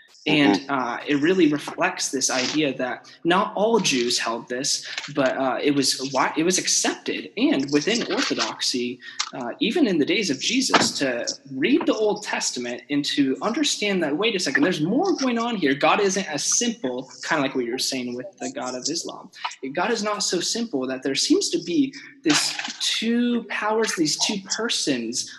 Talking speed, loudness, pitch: 185 wpm, -22 LUFS, 180 Hz